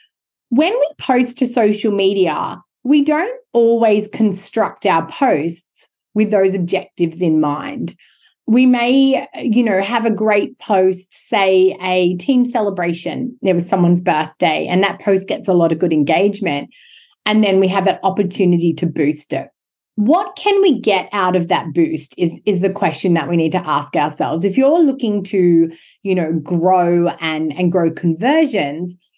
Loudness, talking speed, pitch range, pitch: -16 LUFS, 165 wpm, 175-230 Hz, 190 Hz